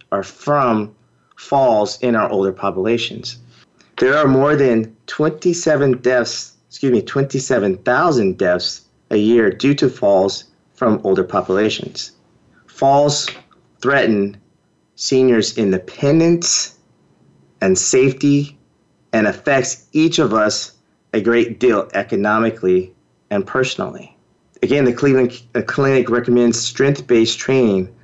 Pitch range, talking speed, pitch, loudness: 110-140 Hz, 105 wpm, 120 Hz, -16 LUFS